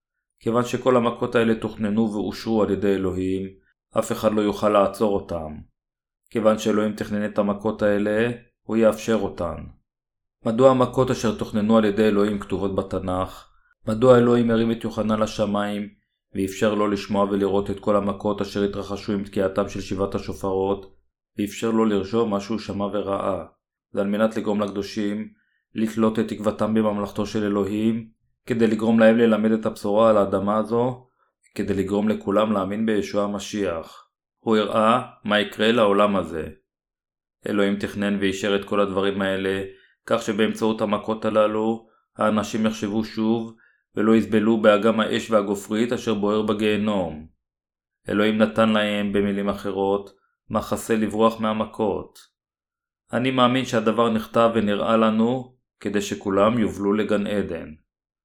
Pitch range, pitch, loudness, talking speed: 100-110 Hz, 105 Hz, -22 LUFS, 135 wpm